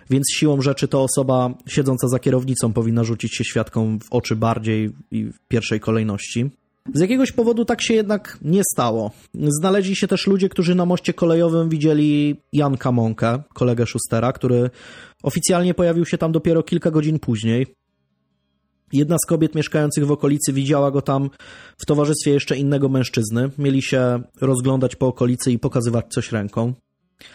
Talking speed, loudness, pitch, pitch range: 160 wpm, -19 LUFS, 135 Hz, 120-155 Hz